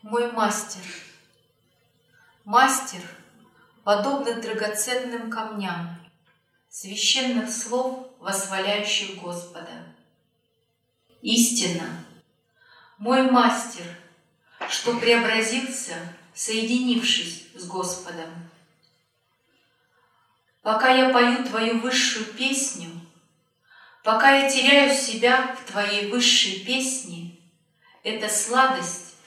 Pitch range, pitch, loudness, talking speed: 175-245 Hz, 215 Hz, -22 LUFS, 70 wpm